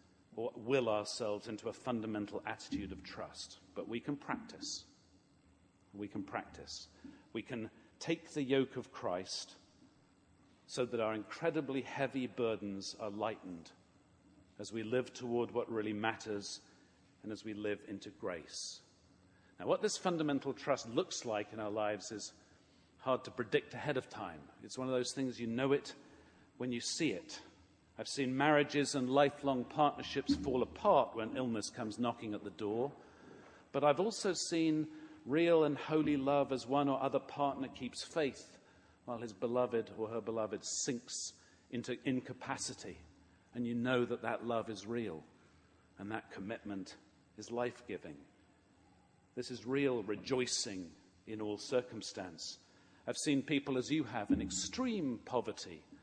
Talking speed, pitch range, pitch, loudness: 150 wpm, 105-135 Hz, 120 Hz, -38 LUFS